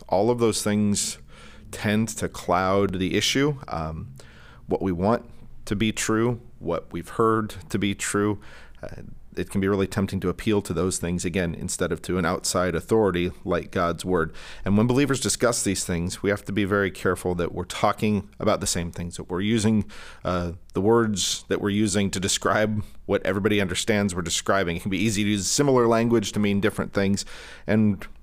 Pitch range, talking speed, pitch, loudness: 95-110 Hz, 195 wpm, 100 Hz, -24 LUFS